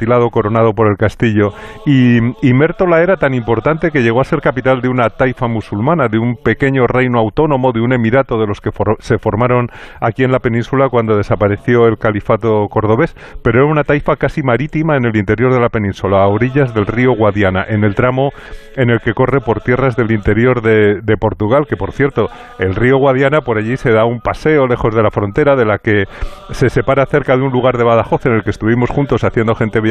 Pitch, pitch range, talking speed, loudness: 120 Hz, 110-130 Hz, 215 wpm, -13 LUFS